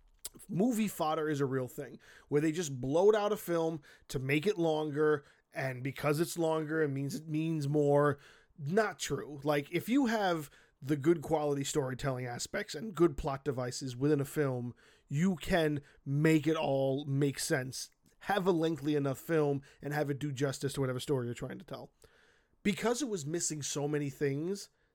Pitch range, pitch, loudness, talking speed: 140-165 Hz, 150 Hz, -33 LUFS, 180 wpm